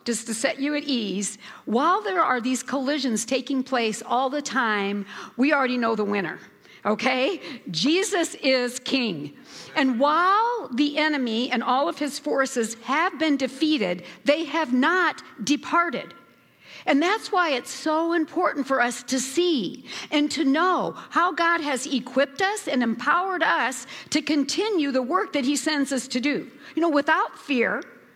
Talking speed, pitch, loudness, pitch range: 160 wpm, 275 Hz, -24 LUFS, 250-315 Hz